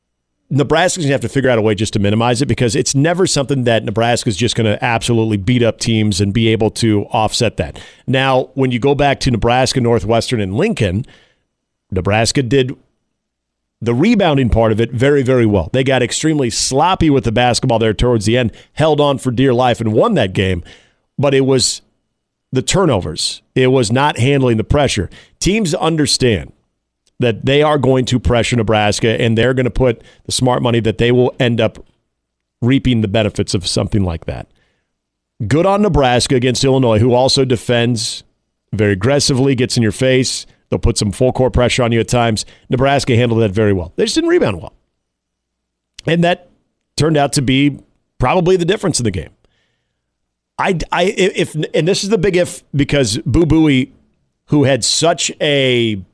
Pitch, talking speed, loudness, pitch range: 120 Hz, 185 wpm, -14 LUFS, 110-140 Hz